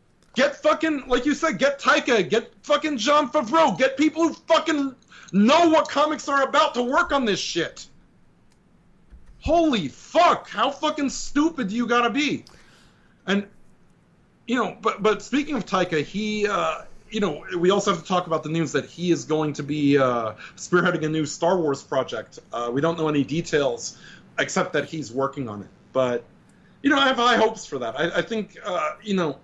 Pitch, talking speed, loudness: 220 Hz, 190 wpm, -23 LUFS